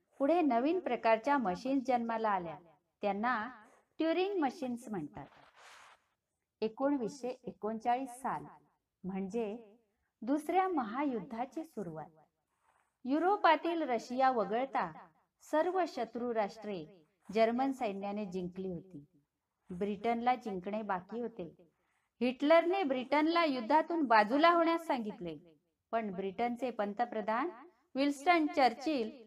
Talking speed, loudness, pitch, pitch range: 75 wpm, -34 LUFS, 240 Hz, 205-285 Hz